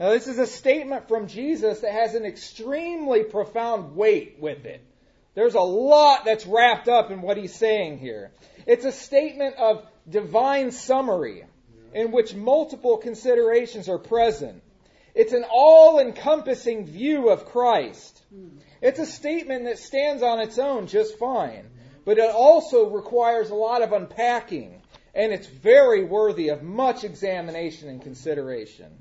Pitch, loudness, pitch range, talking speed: 230 Hz, -21 LUFS, 210-270 Hz, 150 wpm